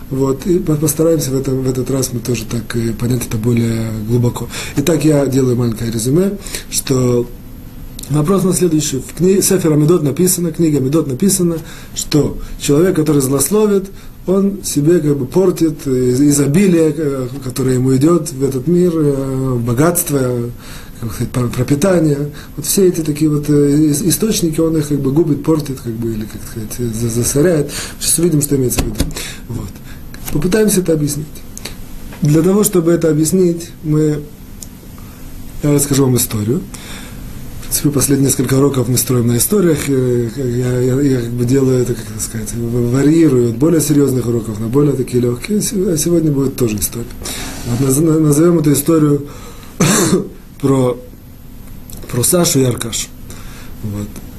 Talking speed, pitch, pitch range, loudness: 145 wpm, 135 Hz, 120-160 Hz, -14 LUFS